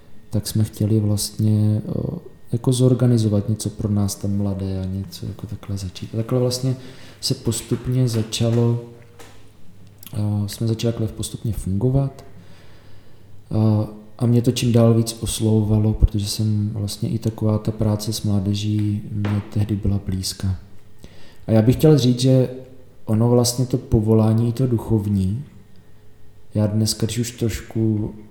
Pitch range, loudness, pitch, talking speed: 105-120 Hz, -21 LUFS, 110 Hz, 135 wpm